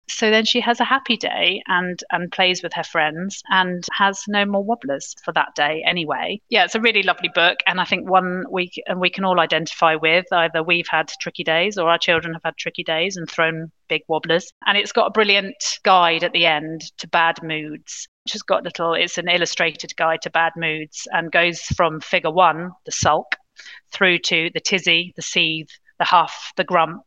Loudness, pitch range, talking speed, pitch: -19 LUFS, 165-190 Hz, 210 wpm, 175 Hz